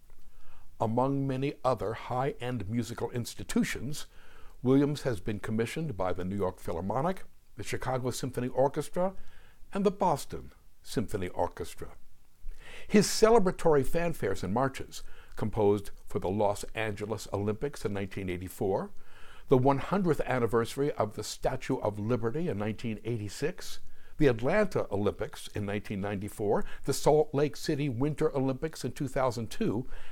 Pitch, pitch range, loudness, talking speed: 125 Hz, 105-140 Hz, -31 LUFS, 120 wpm